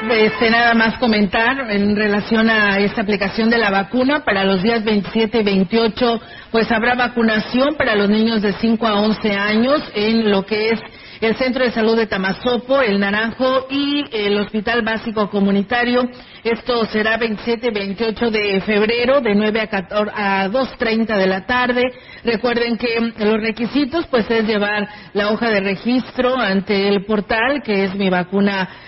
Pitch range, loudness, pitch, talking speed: 205-235 Hz, -17 LUFS, 225 Hz, 165 wpm